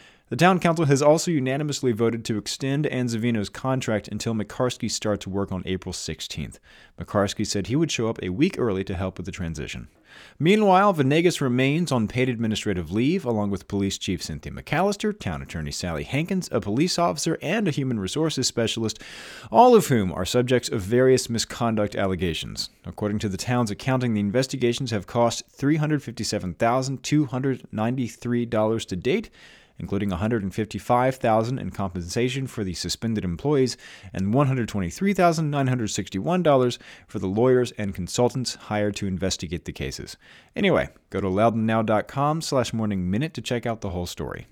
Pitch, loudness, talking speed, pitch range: 115 Hz, -24 LUFS, 150 wpm, 100-130 Hz